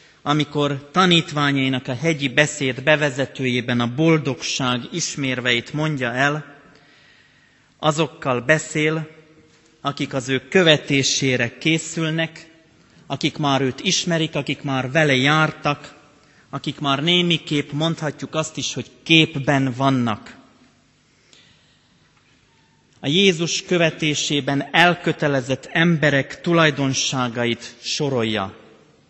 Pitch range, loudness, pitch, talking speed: 135-160 Hz, -20 LUFS, 145 Hz, 90 wpm